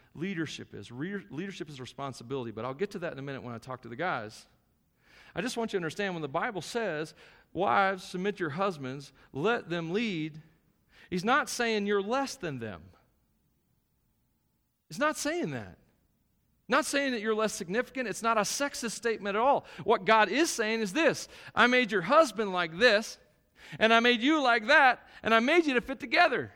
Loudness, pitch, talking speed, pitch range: -28 LUFS, 205 Hz, 195 wpm, 165-245 Hz